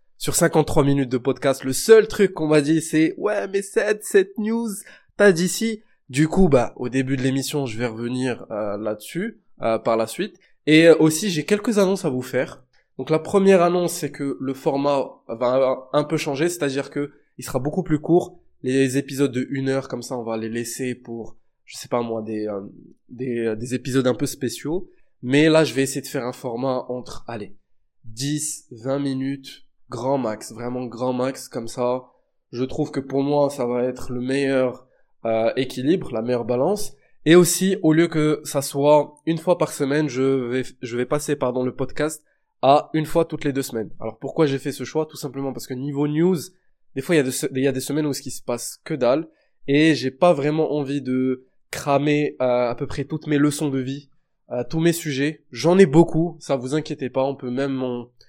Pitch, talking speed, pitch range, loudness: 140 Hz, 215 wpm, 125-155 Hz, -22 LUFS